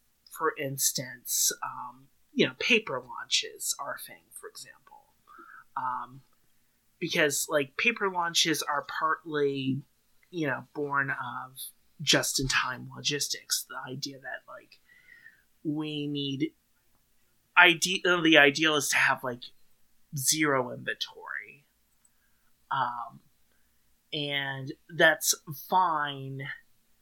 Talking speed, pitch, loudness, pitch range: 95 wpm, 150 Hz, -27 LUFS, 135-175 Hz